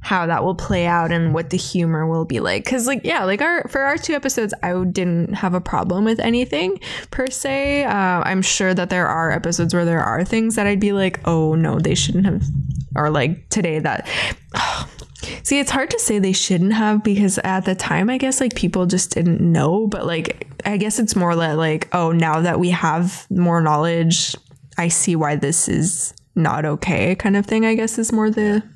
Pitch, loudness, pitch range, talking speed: 180 Hz, -19 LUFS, 165-215 Hz, 215 wpm